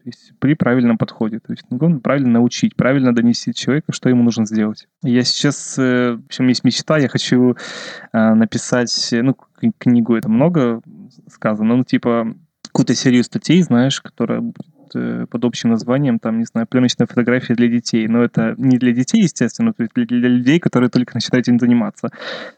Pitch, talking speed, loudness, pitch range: 125 Hz, 165 wpm, -16 LUFS, 115-130 Hz